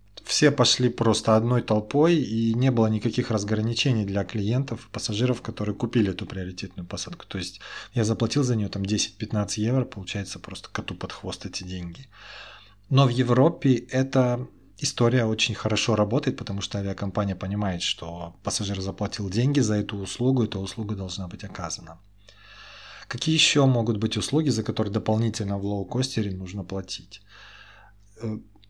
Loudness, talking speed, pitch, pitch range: -25 LUFS, 145 wpm, 110 Hz, 100-120 Hz